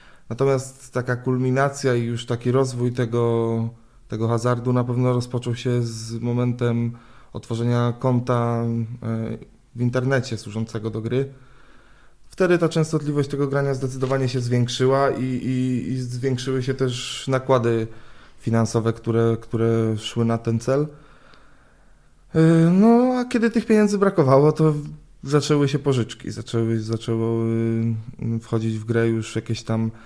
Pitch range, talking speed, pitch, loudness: 115-135 Hz, 125 wpm, 125 Hz, -22 LUFS